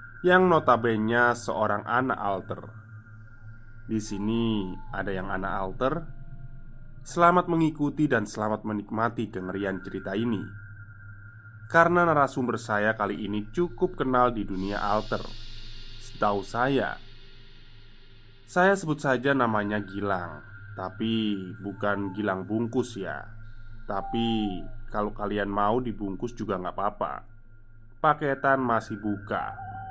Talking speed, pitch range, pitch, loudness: 105 wpm, 105-125 Hz, 110 Hz, -27 LUFS